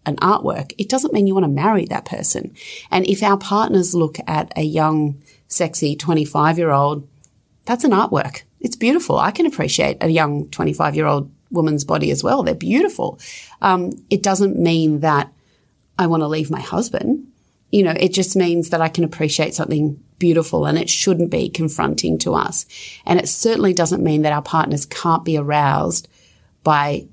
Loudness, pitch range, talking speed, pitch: -18 LUFS, 150-190 Hz, 185 wpm, 160 Hz